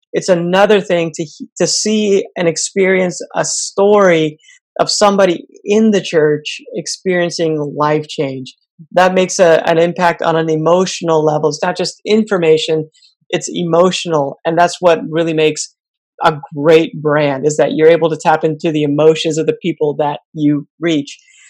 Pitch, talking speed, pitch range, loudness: 165 Hz, 155 wpm, 155-185 Hz, -13 LUFS